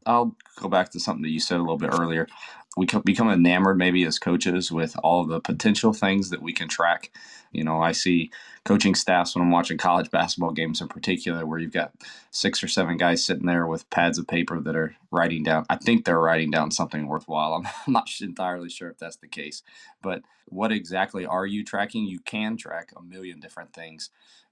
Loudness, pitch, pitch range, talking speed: -24 LUFS, 85 Hz, 80-95 Hz, 210 wpm